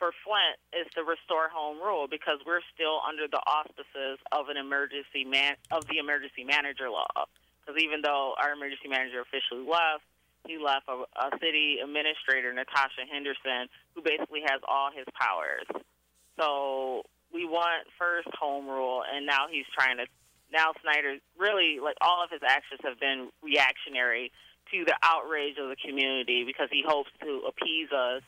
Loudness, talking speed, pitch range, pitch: -29 LUFS, 165 wpm, 135-155 Hz, 145 Hz